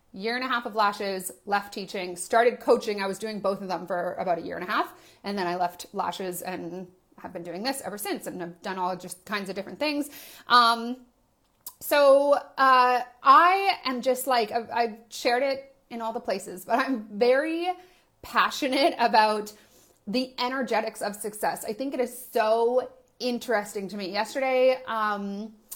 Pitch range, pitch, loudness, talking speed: 195-255 Hz, 230 Hz, -26 LUFS, 180 wpm